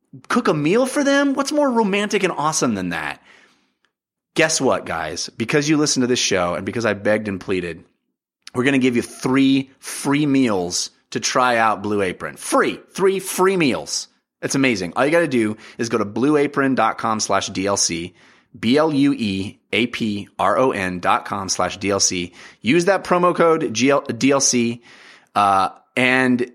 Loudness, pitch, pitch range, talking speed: -19 LUFS, 125 Hz, 105-150 Hz, 150 wpm